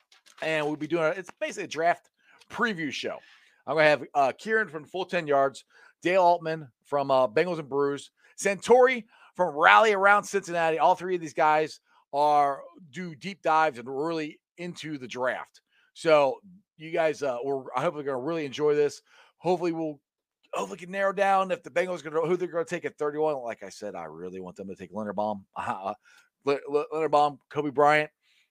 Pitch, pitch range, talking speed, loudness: 155 Hz, 145-180 Hz, 190 wpm, -26 LUFS